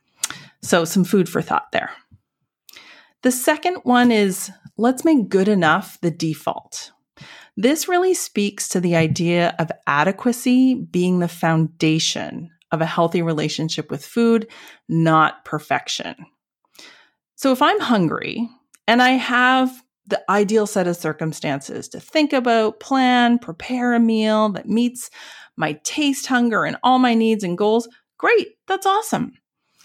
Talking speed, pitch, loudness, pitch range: 135 wpm, 220 Hz, -19 LUFS, 175-255 Hz